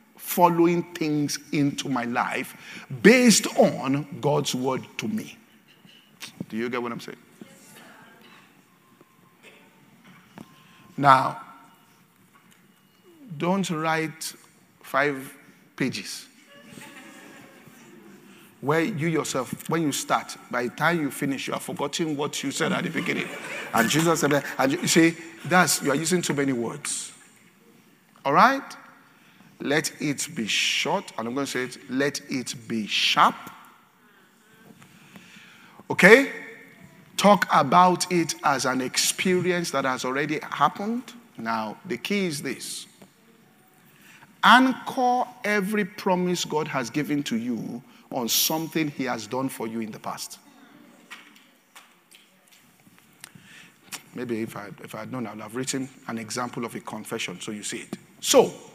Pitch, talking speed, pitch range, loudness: 165 Hz, 130 wpm, 135-200 Hz, -24 LUFS